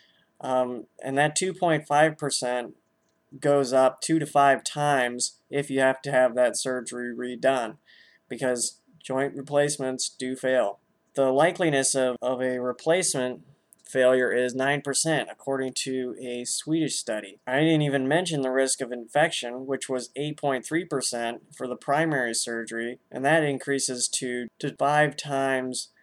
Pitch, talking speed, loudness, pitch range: 130 Hz, 135 wpm, -25 LUFS, 125-145 Hz